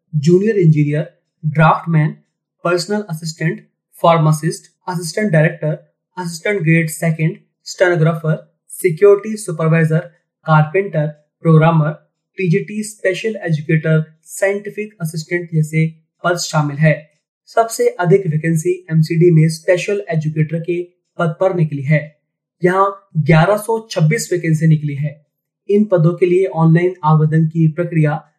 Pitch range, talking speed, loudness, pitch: 155-185 Hz, 105 wpm, -16 LUFS, 165 Hz